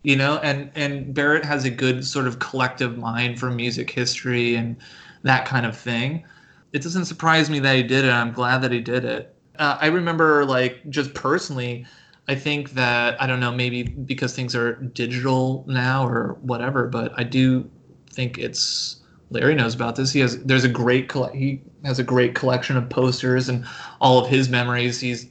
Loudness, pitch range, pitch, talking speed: -21 LUFS, 125-135 Hz, 130 Hz, 195 wpm